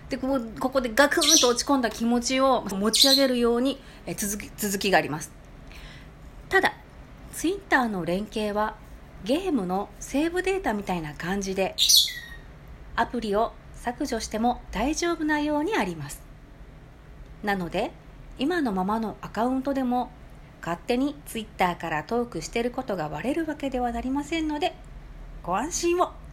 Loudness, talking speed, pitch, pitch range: -25 LUFS, 310 characters per minute, 240 Hz, 205-280 Hz